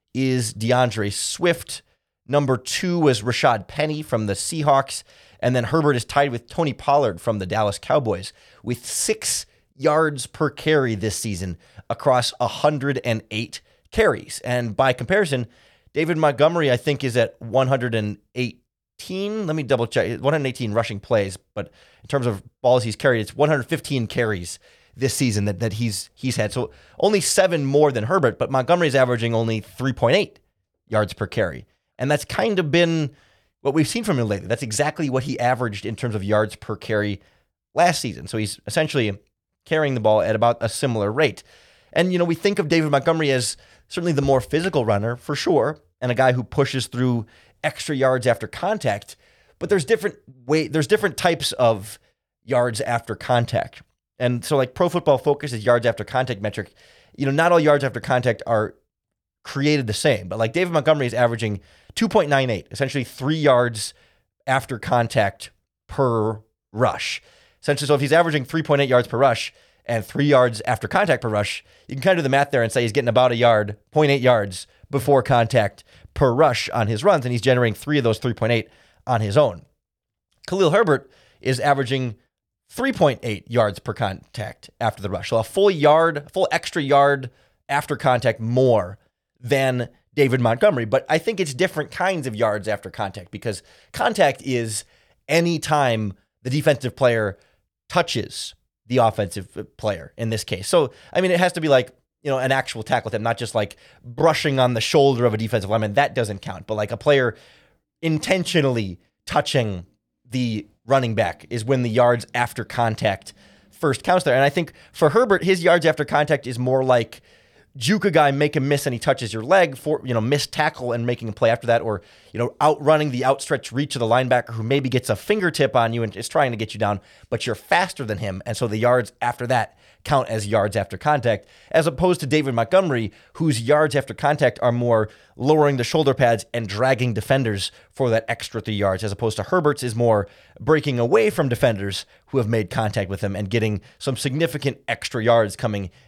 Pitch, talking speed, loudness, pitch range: 125 Hz, 185 wpm, -21 LUFS, 110-145 Hz